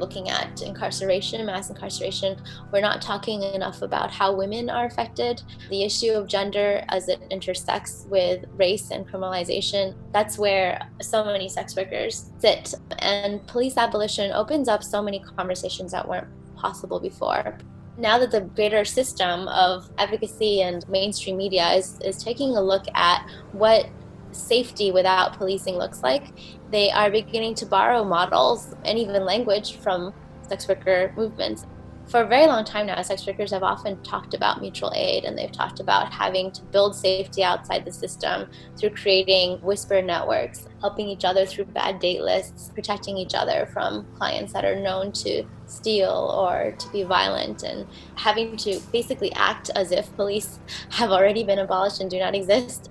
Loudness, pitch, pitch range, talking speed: -24 LUFS, 200 Hz, 190-215 Hz, 165 wpm